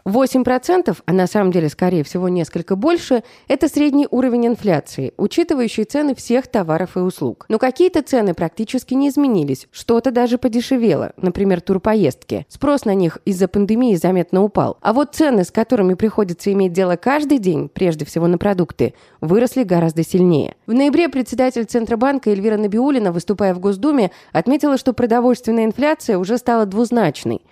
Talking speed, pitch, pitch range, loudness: 155 wpm, 220 Hz, 185-255 Hz, -17 LUFS